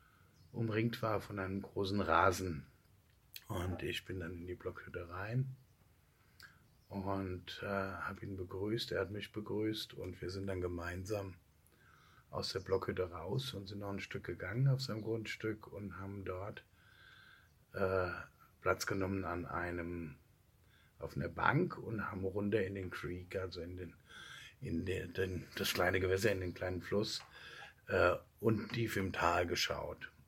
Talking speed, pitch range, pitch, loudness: 155 wpm, 90-110 Hz, 95 Hz, -39 LUFS